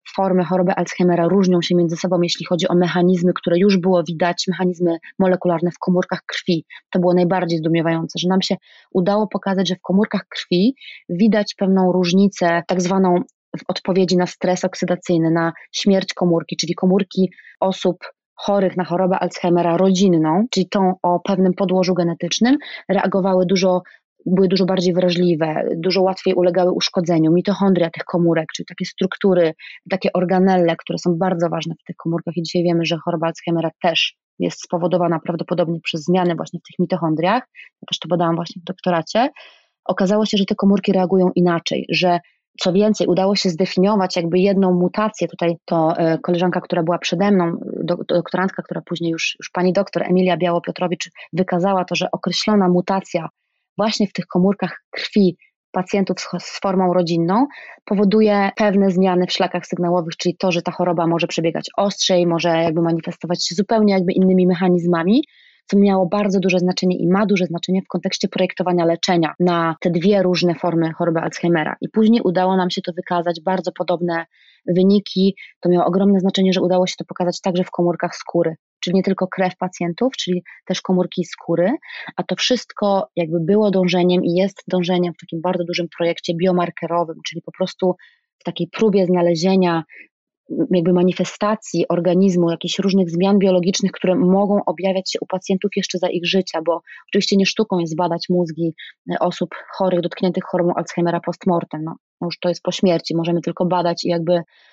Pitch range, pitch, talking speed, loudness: 175-190 Hz, 180 Hz, 165 wpm, -18 LUFS